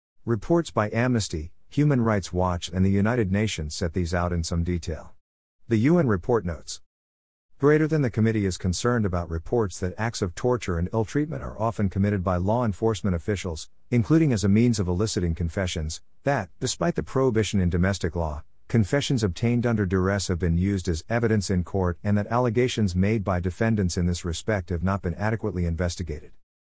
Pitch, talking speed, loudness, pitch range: 100 Hz, 185 wpm, -25 LUFS, 90-115 Hz